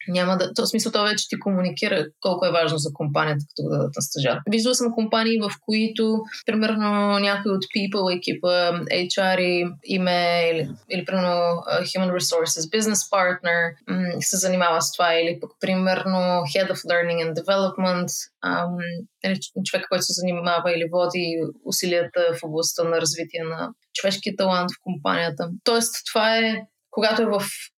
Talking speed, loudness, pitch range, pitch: 155 wpm, -22 LUFS, 170-200 Hz, 180 Hz